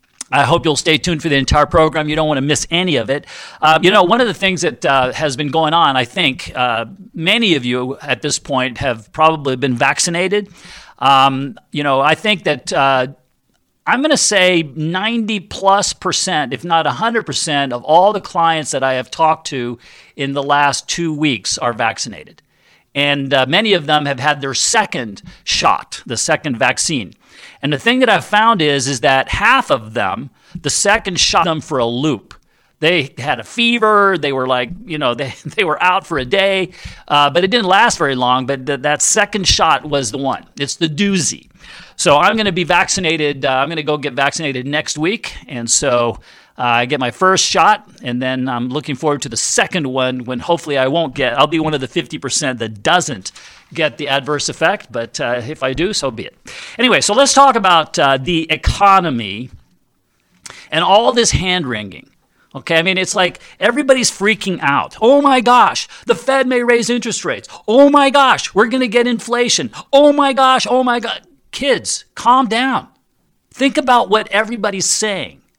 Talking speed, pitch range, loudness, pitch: 200 wpm, 135-200 Hz, -14 LUFS, 155 Hz